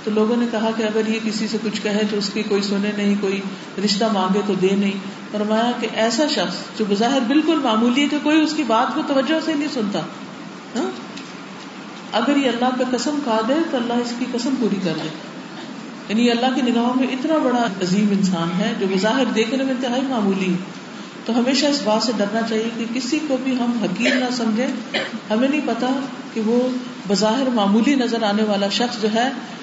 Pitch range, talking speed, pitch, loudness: 210-260 Hz, 210 wpm, 235 Hz, -20 LUFS